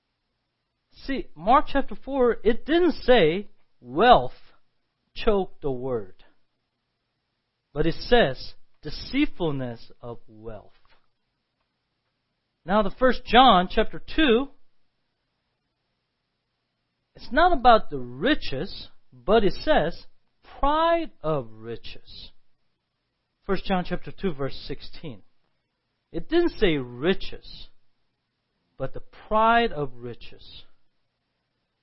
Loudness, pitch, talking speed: -23 LUFS, 180 Hz, 90 wpm